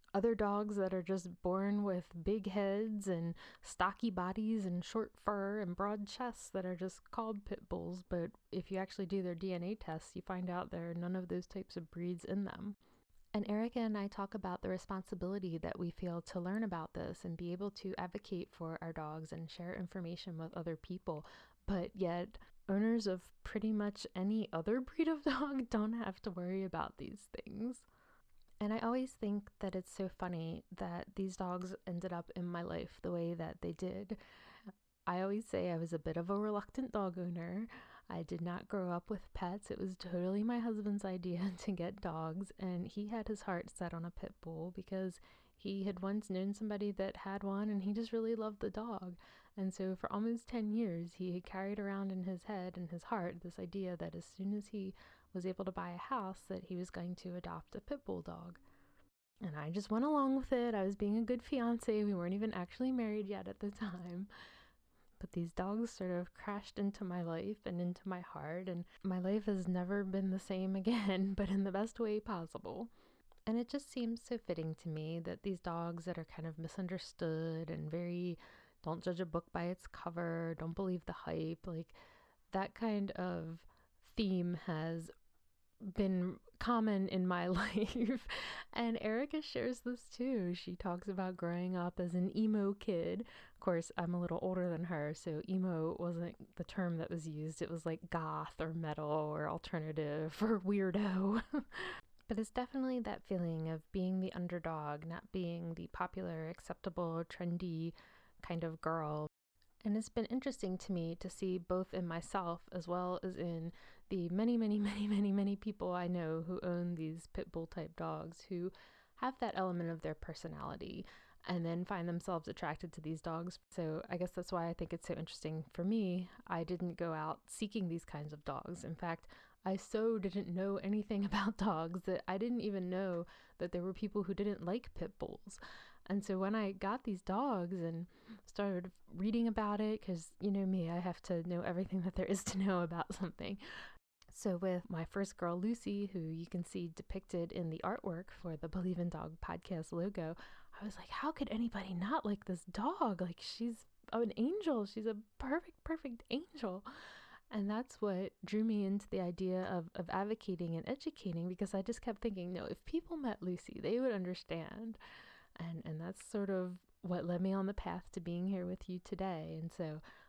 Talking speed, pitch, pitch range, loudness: 195 wpm, 185 Hz, 175-210 Hz, -41 LUFS